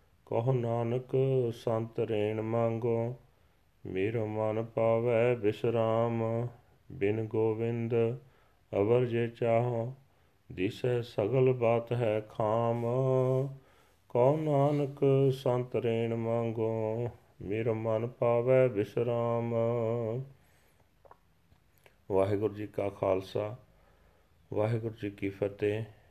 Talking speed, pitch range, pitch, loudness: 75 wpm, 105-120 Hz, 115 Hz, -31 LUFS